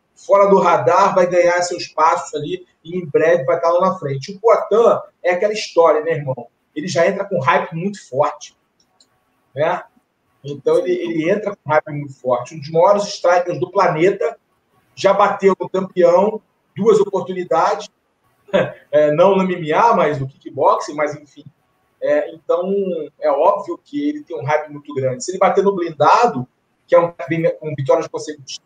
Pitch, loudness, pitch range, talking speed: 175 Hz, -17 LUFS, 155-195 Hz, 170 wpm